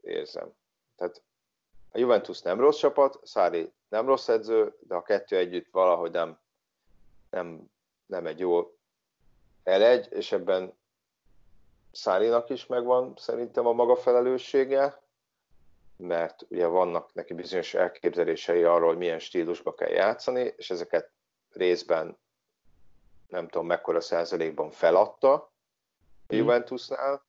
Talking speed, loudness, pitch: 115 wpm, -27 LUFS, 395 Hz